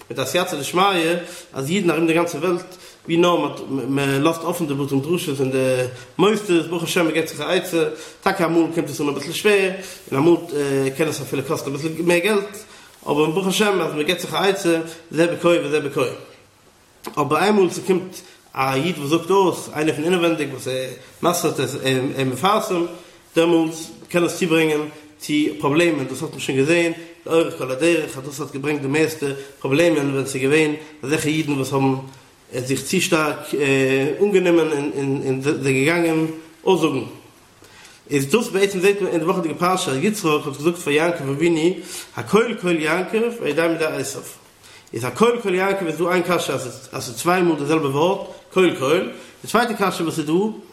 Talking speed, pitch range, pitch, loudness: 190 wpm, 145-180 Hz, 165 Hz, -20 LUFS